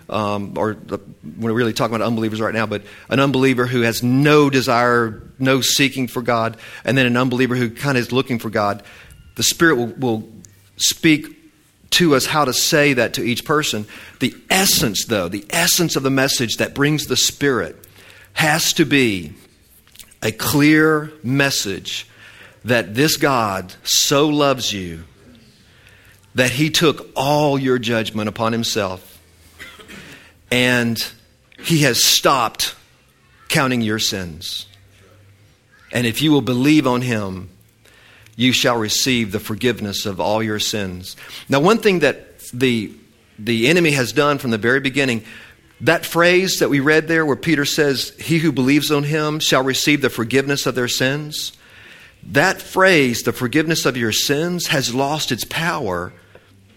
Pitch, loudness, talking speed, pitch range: 125 Hz, -17 LUFS, 155 wpm, 110-145 Hz